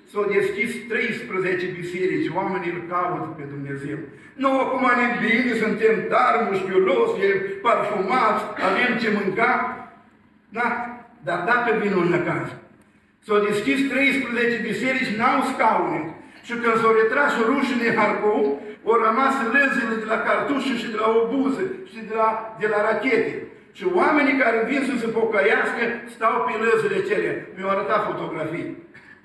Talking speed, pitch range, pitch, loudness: 150 wpm, 210-245 Hz, 225 Hz, -21 LUFS